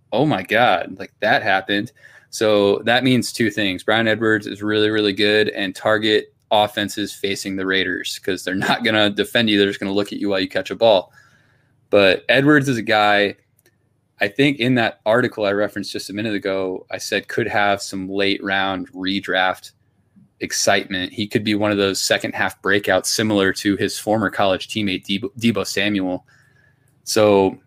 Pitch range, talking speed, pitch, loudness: 100-115 Hz, 185 wpm, 105 Hz, -19 LUFS